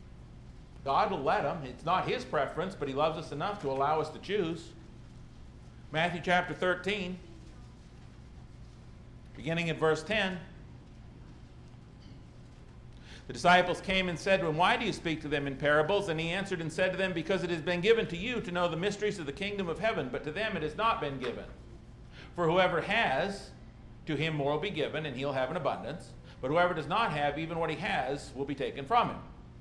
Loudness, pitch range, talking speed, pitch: -31 LUFS, 150-190 Hz, 200 wpm, 170 Hz